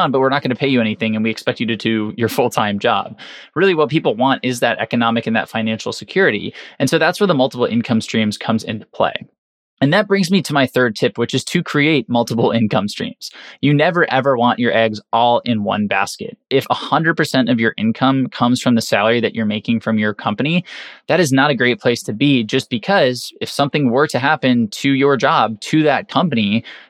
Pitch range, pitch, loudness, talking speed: 115-140 Hz, 125 Hz, -16 LUFS, 225 wpm